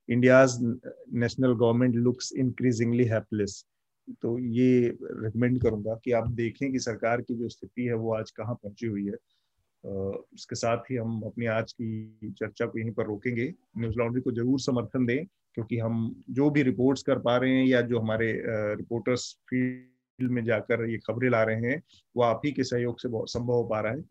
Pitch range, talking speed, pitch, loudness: 115-125 Hz, 185 wpm, 120 Hz, -28 LUFS